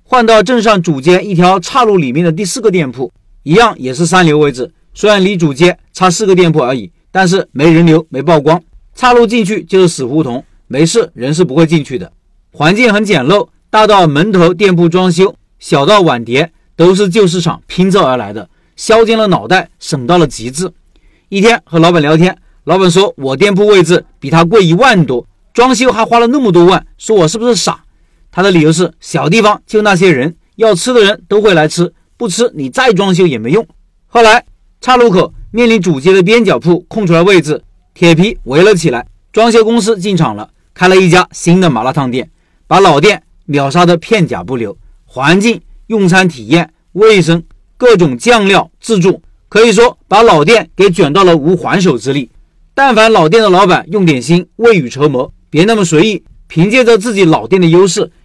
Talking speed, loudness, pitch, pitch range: 285 characters per minute, -9 LUFS, 180 Hz, 160-210 Hz